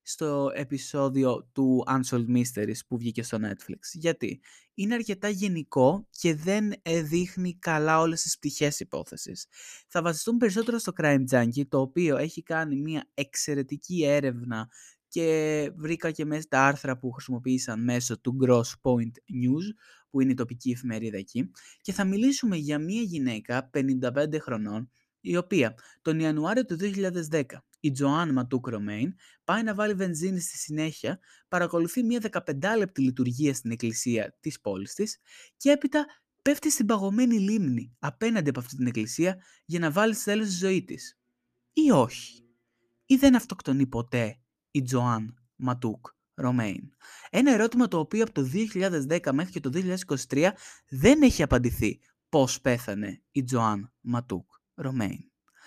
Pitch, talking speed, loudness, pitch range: 145 Hz, 145 wpm, -27 LUFS, 125-185 Hz